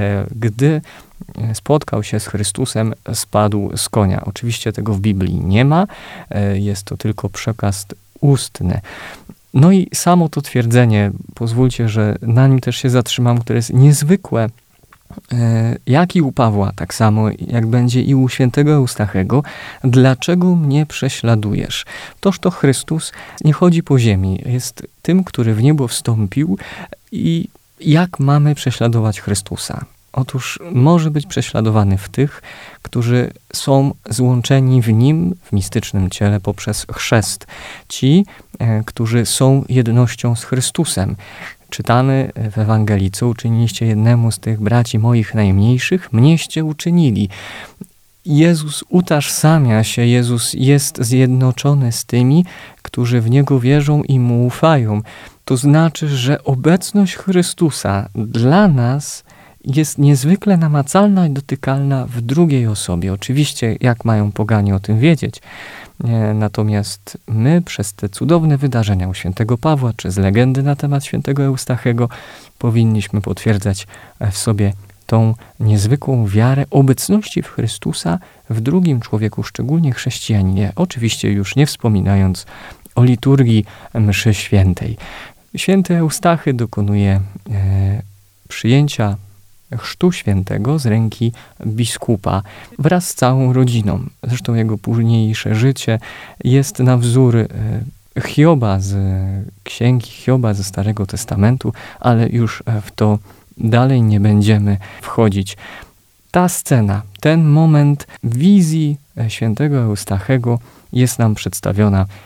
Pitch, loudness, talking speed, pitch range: 120 Hz, -15 LUFS, 120 wpm, 105-140 Hz